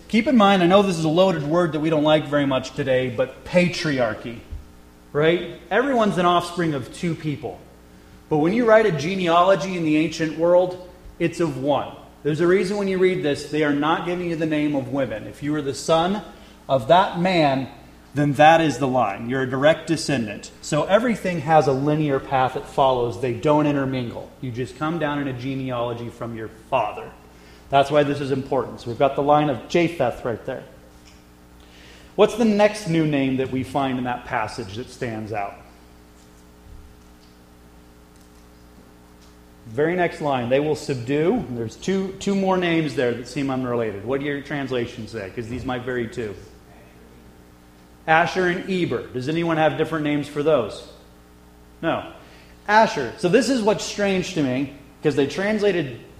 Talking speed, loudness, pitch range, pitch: 180 wpm, -21 LUFS, 115-165 Hz, 140 Hz